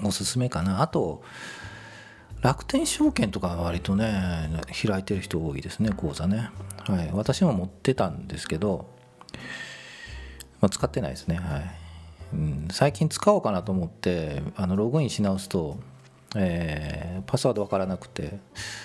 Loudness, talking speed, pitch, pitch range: -27 LUFS, 285 characters per minute, 95 Hz, 85-110 Hz